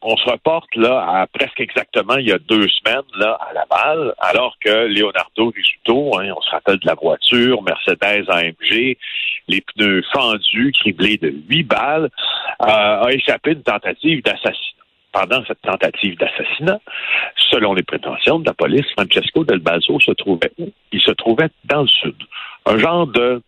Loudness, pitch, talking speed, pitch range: -15 LUFS, 120 Hz, 170 wpm, 105-145 Hz